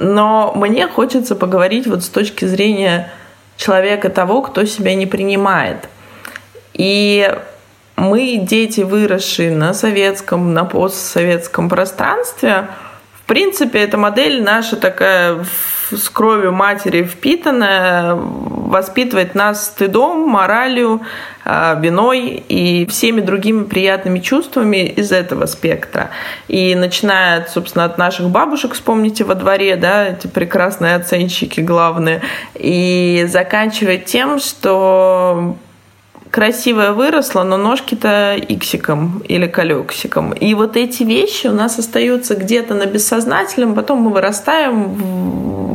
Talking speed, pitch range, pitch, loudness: 110 wpm, 185-225 Hz, 200 Hz, -13 LUFS